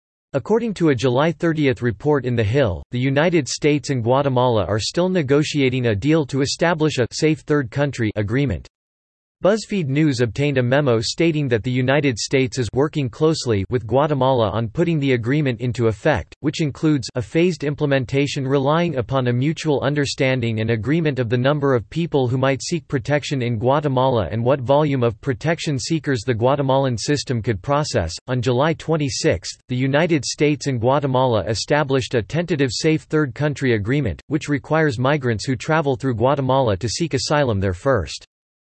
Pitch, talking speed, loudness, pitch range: 135 Hz, 170 wpm, -20 LUFS, 125-150 Hz